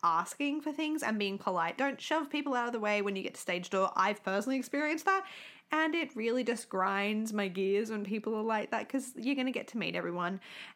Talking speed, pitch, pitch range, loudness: 240 wpm, 225 Hz, 200-275 Hz, -33 LUFS